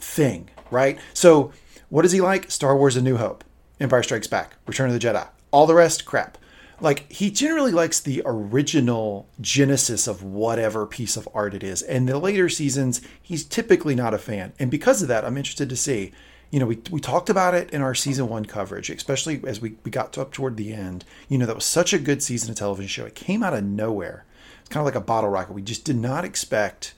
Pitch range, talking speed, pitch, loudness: 110-150 Hz, 230 wpm, 130 Hz, -22 LUFS